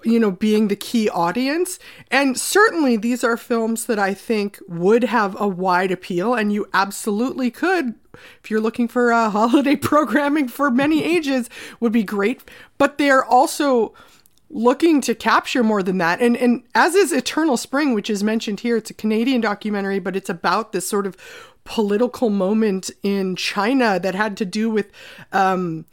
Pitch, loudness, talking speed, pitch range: 230 Hz, -19 LUFS, 175 wpm, 205-260 Hz